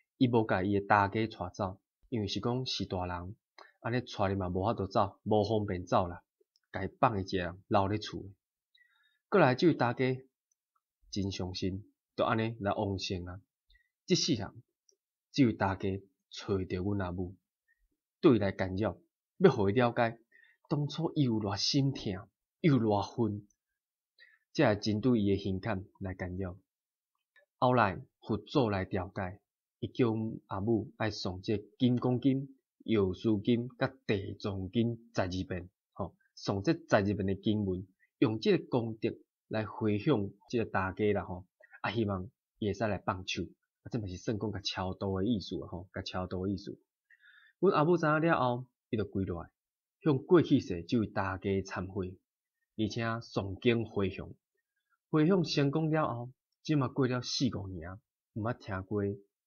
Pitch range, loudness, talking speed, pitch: 95-125 Hz, -32 LUFS, 220 characters per minute, 105 Hz